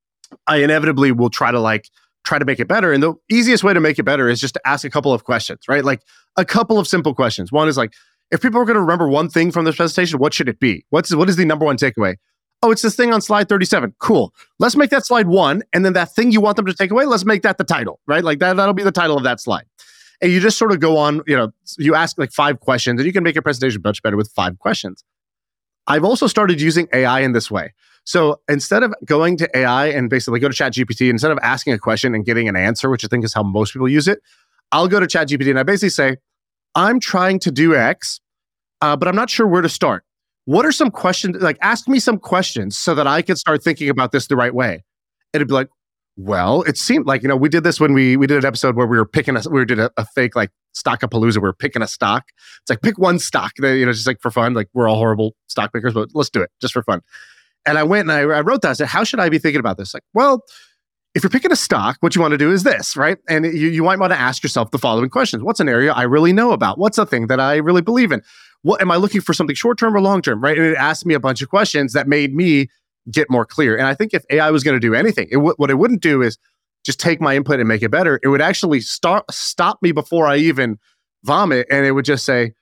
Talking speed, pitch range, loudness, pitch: 275 wpm, 130-185 Hz, -16 LUFS, 150 Hz